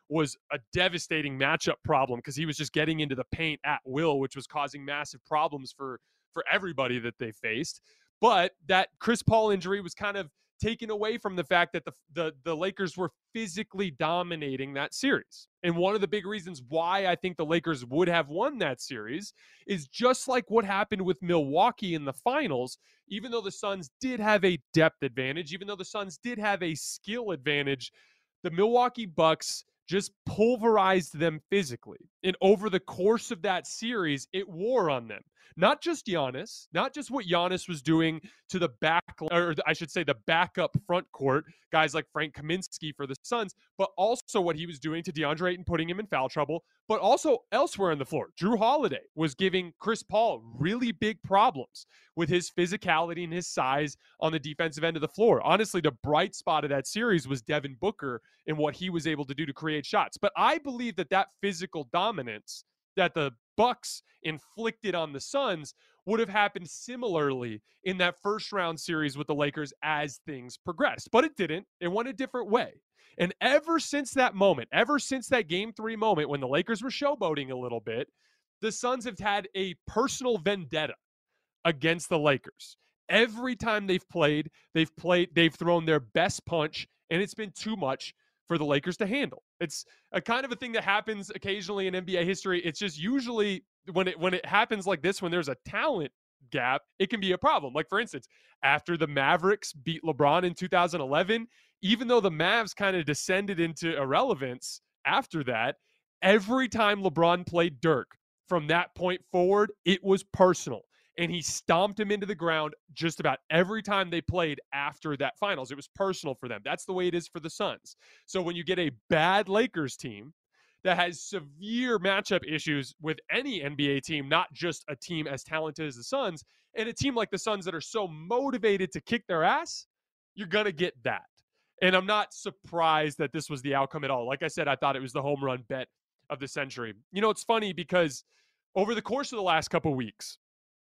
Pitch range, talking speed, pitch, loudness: 155-205 Hz, 200 wpm, 175 Hz, -29 LUFS